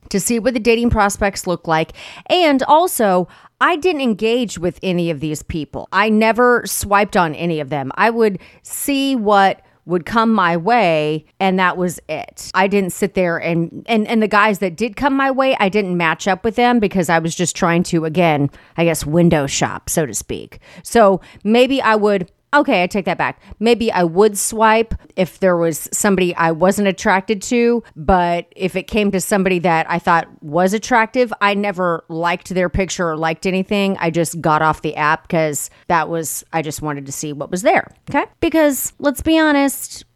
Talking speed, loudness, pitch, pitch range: 200 wpm, -16 LUFS, 190 Hz, 165-225 Hz